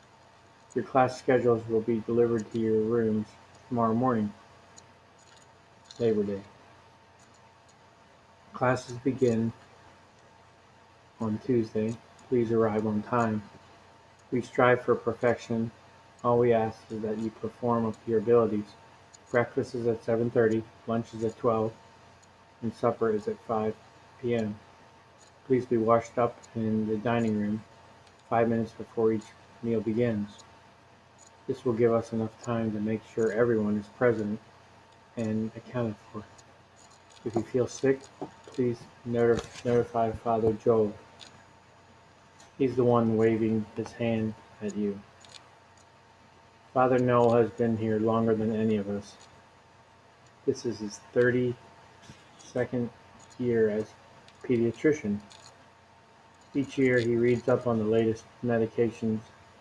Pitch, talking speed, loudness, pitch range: 115 Hz, 125 wpm, -28 LUFS, 110-120 Hz